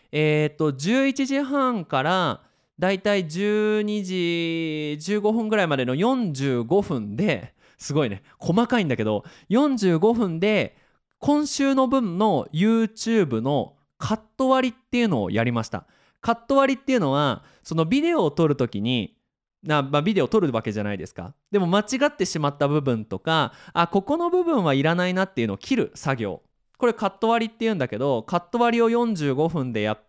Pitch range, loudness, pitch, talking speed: 145-230 Hz, -23 LUFS, 190 Hz, 305 characters per minute